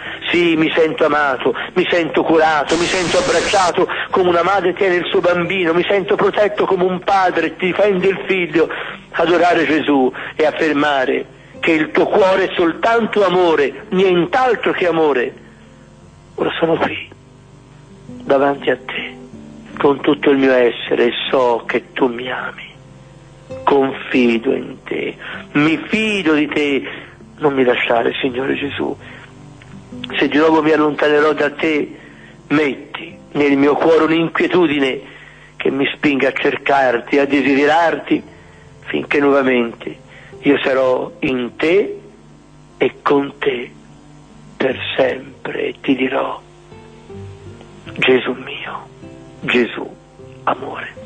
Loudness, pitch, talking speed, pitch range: -16 LUFS, 155 Hz, 125 wpm, 135-180 Hz